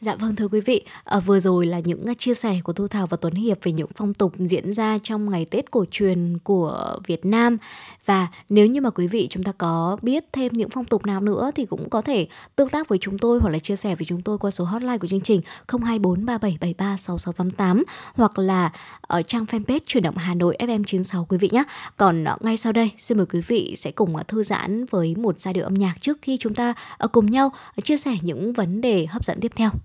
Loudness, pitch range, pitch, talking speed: -22 LUFS, 180-230 Hz, 205 Hz, 235 wpm